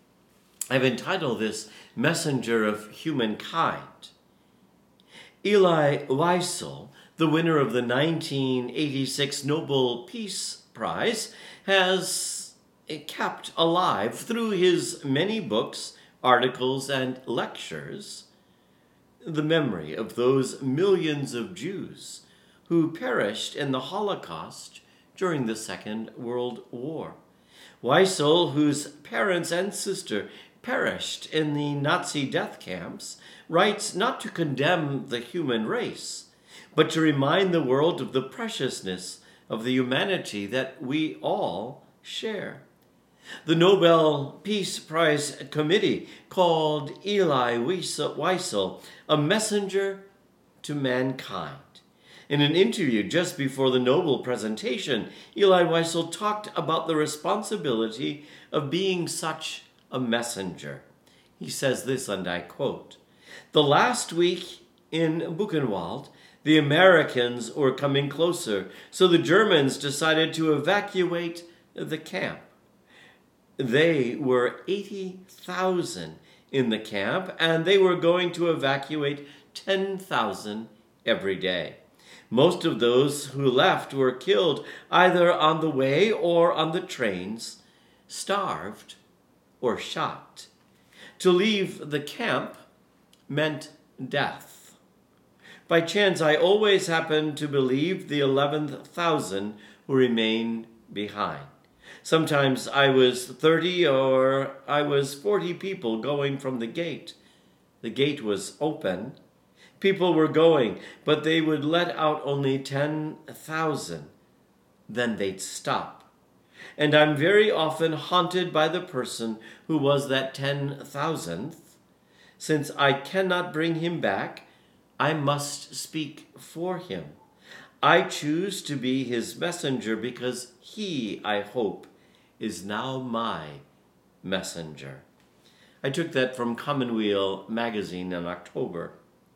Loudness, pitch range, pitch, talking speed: -25 LUFS, 130-175 Hz, 150 Hz, 110 wpm